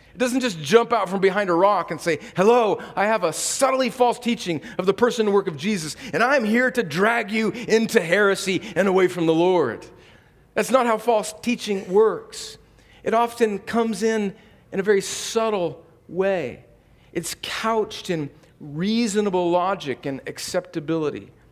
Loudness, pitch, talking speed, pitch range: -22 LUFS, 205 Hz, 165 wpm, 170-230 Hz